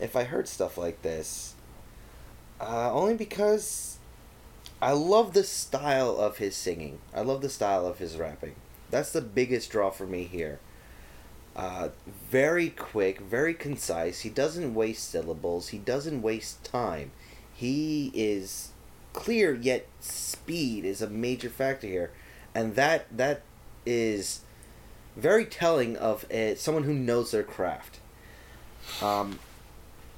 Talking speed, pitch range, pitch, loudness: 135 wpm, 100-150 Hz, 120 Hz, -29 LUFS